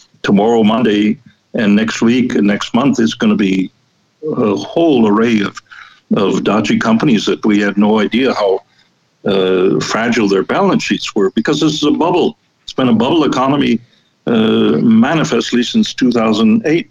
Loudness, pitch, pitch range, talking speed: -13 LUFS, 110 Hz, 105-125 Hz, 160 wpm